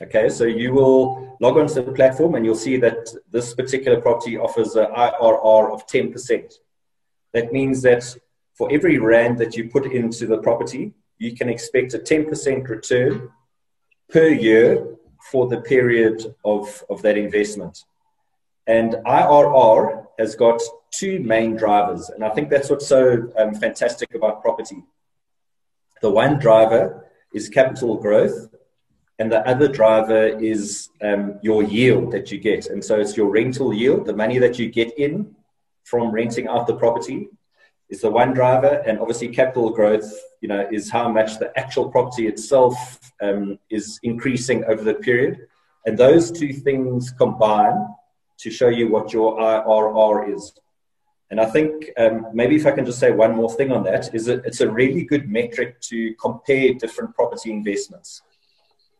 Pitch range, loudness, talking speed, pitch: 110-135 Hz, -18 LUFS, 160 wpm, 115 Hz